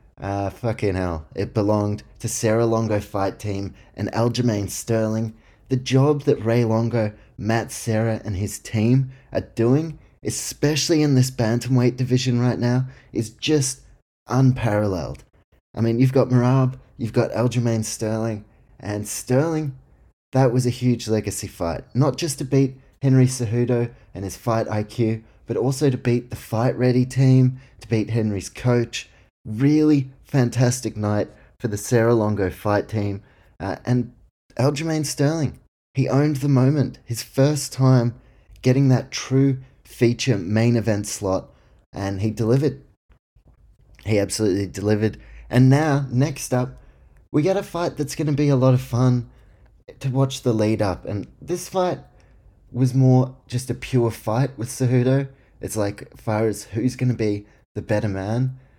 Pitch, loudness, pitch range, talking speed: 120 Hz, -22 LUFS, 105-130 Hz, 155 wpm